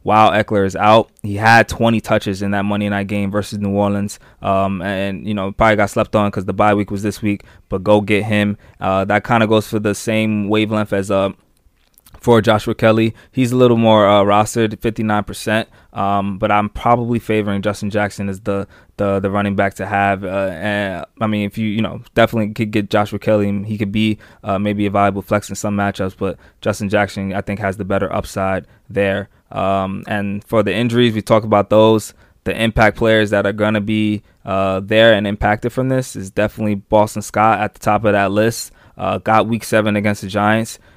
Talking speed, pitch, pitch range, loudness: 215 wpm, 105 Hz, 100-110 Hz, -17 LUFS